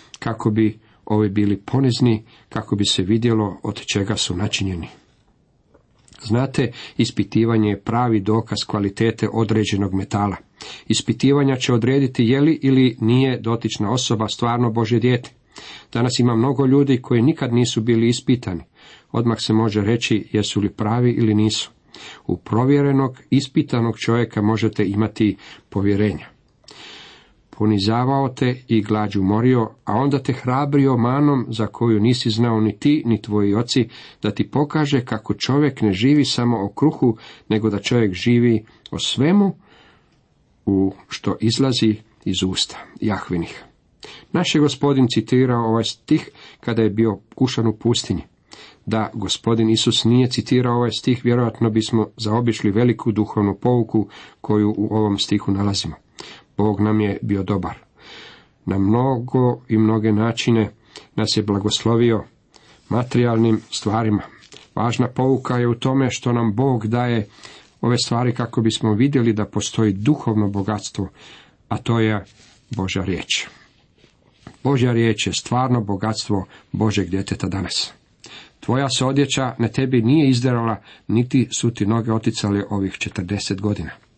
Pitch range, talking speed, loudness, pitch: 105-125 Hz, 135 wpm, -19 LUFS, 115 Hz